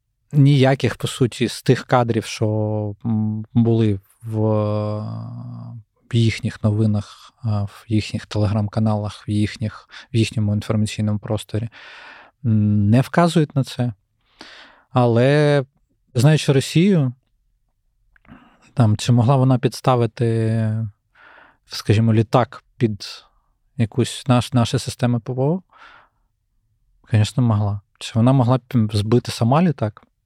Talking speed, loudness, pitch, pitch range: 95 wpm, -19 LUFS, 115 Hz, 110-125 Hz